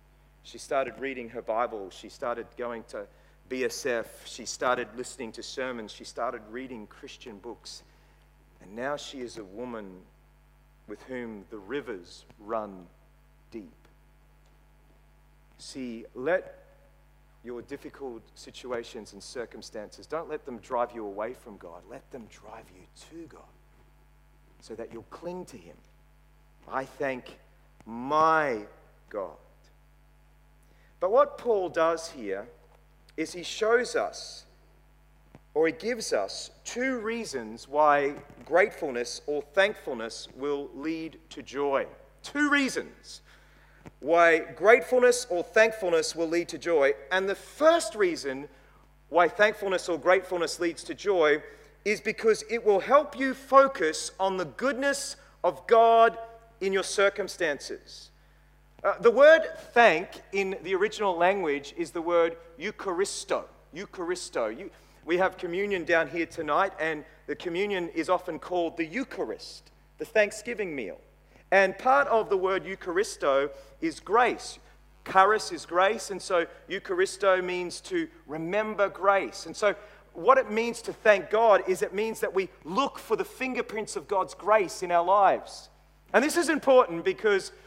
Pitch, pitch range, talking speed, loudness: 185 Hz, 155-235 Hz, 135 wpm, -27 LUFS